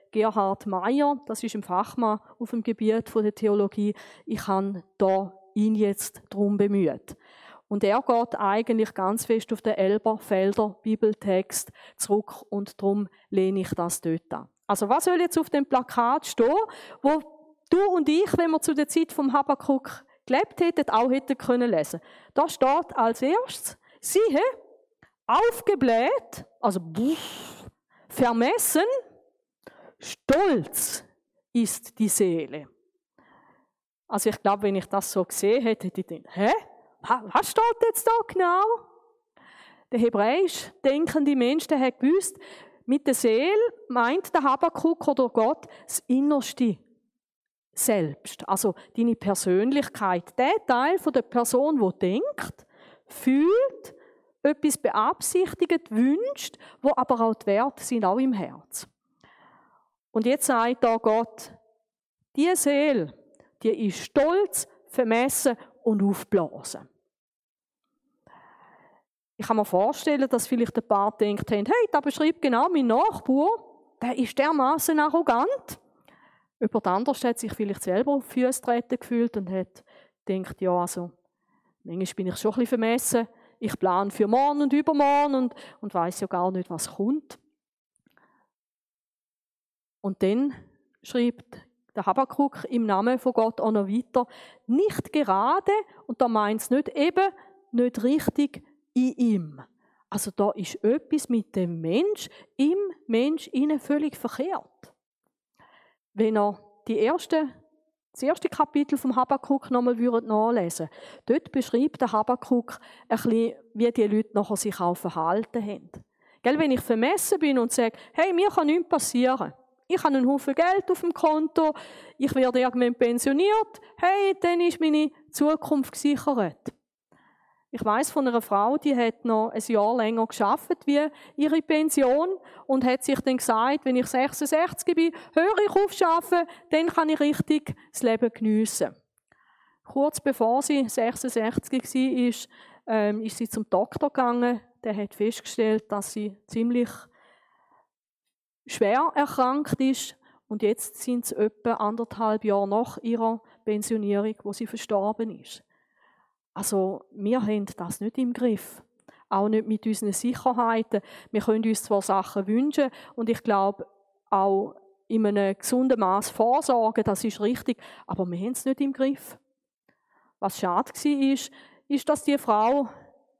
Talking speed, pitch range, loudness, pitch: 140 wpm, 215-295 Hz, -25 LUFS, 245 Hz